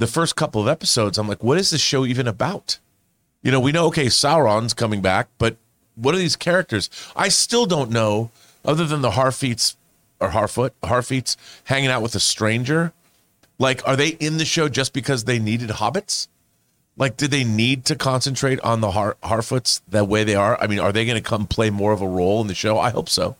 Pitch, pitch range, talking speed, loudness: 125 Hz, 110-140 Hz, 220 wpm, -20 LUFS